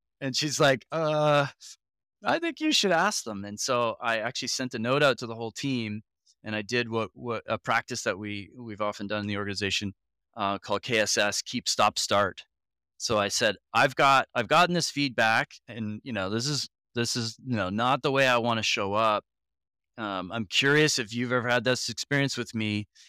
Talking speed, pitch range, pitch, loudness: 215 wpm, 105-135 Hz, 120 Hz, -27 LUFS